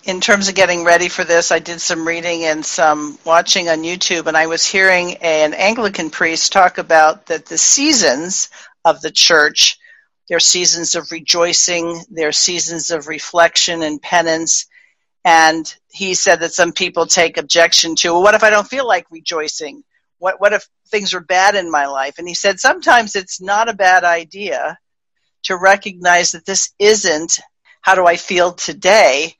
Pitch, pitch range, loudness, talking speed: 175 Hz, 165-190 Hz, -13 LUFS, 175 wpm